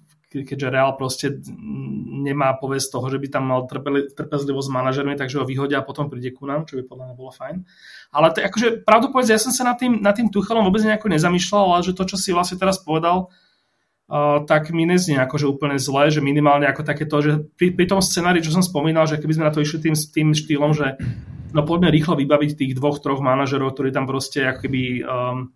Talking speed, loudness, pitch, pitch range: 220 wpm, -19 LUFS, 150 Hz, 135-175 Hz